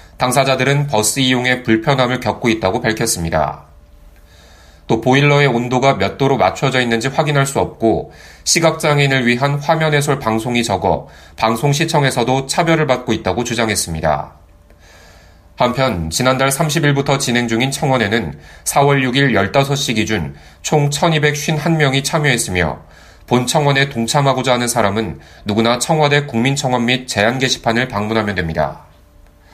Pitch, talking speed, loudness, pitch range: 125 Hz, 310 characters per minute, -15 LUFS, 100-140 Hz